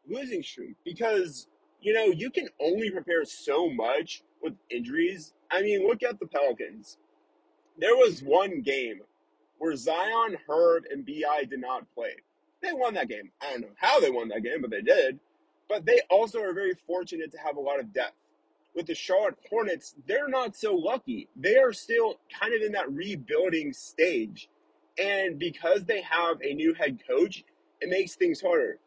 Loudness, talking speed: -28 LUFS, 180 wpm